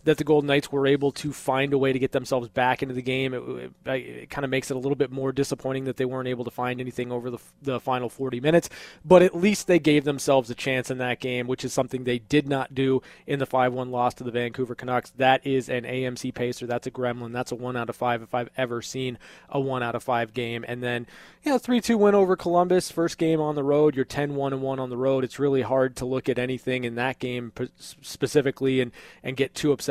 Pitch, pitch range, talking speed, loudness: 130 Hz, 125-140 Hz, 255 wpm, -25 LUFS